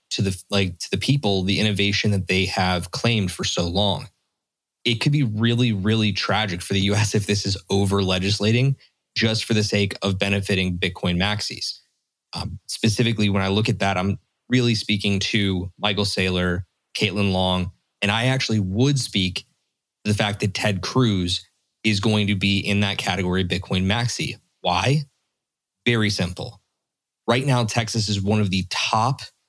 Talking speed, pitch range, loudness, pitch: 170 wpm, 95-110 Hz, -22 LUFS, 100 Hz